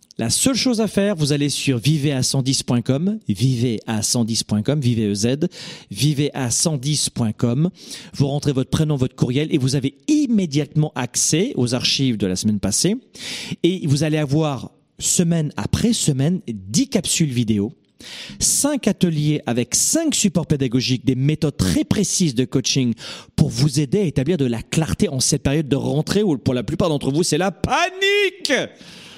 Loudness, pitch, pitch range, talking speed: -19 LUFS, 150 Hz, 130-175 Hz, 150 wpm